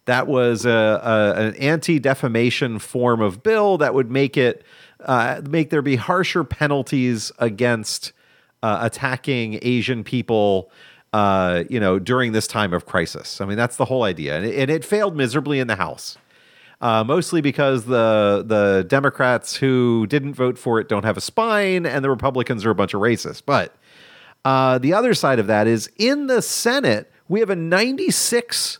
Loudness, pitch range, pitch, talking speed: -19 LUFS, 110-145 Hz, 125 Hz, 180 wpm